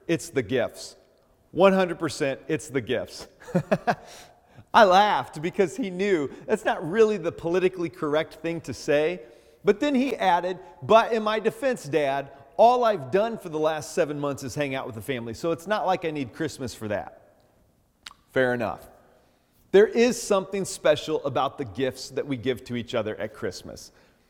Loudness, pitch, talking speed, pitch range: -25 LUFS, 155 Hz, 175 wpm, 135-195 Hz